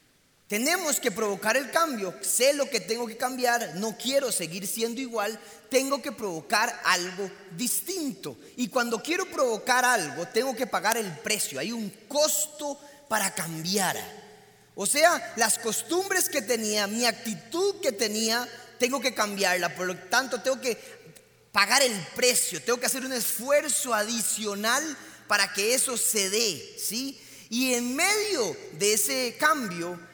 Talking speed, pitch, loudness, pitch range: 150 wpm, 235 Hz, -26 LUFS, 210-270 Hz